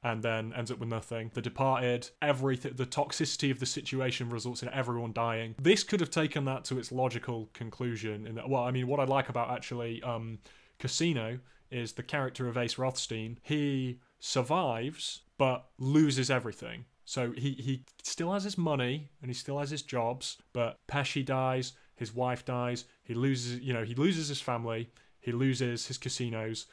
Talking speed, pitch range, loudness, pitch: 180 wpm, 120-140 Hz, -33 LUFS, 130 Hz